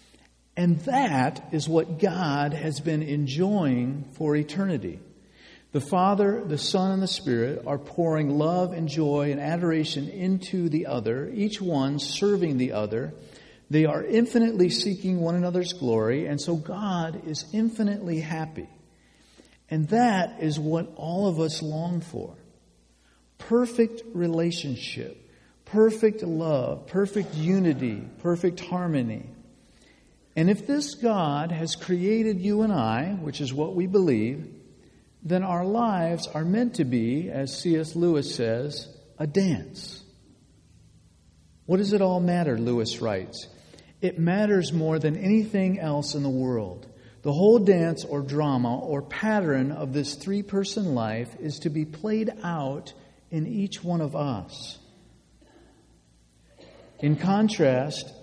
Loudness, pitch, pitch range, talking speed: -26 LUFS, 160 Hz, 140-190 Hz, 135 wpm